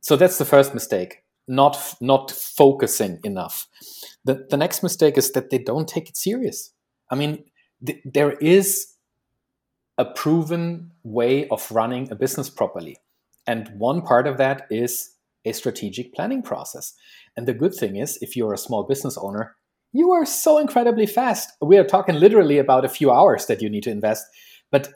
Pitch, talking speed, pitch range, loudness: 140 Hz, 175 wpm, 125-175 Hz, -20 LUFS